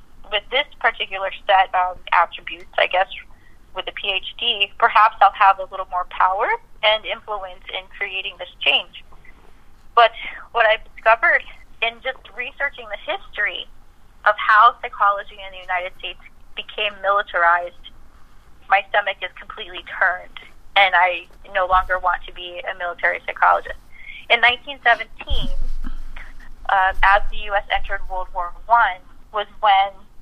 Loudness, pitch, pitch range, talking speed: -19 LUFS, 200 Hz, 185-220 Hz, 140 wpm